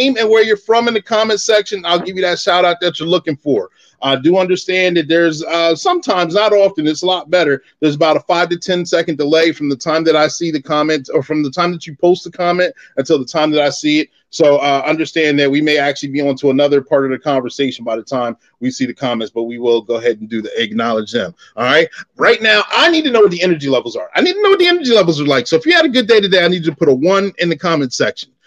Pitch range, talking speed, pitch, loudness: 145-195 Hz, 290 wpm, 165 Hz, -14 LUFS